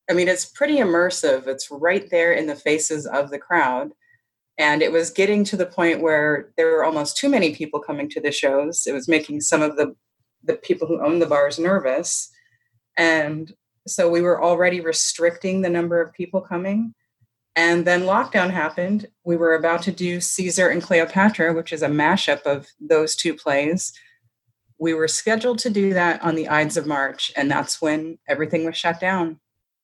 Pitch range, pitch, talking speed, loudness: 150-180 Hz, 165 Hz, 190 wpm, -20 LUFS